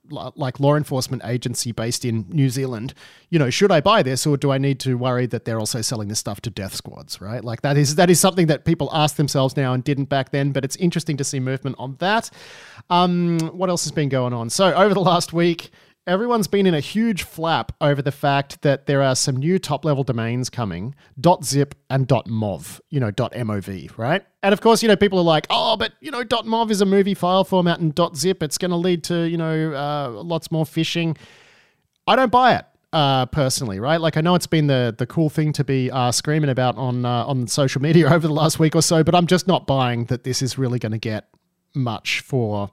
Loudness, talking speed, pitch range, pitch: -20 LUFS, 235 wpm, 125-170 Hz, 145 Hz